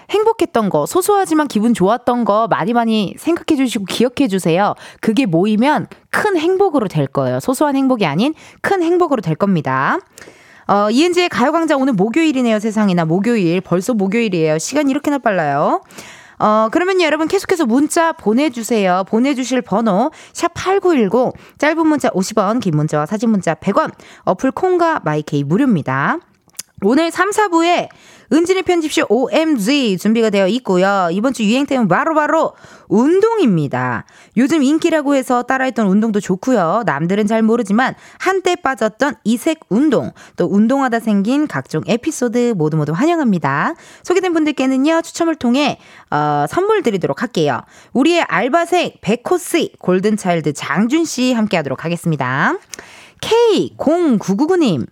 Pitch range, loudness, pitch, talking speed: 195-315 Hz, -15 LUFS, 245 Hz, 335 characters per minute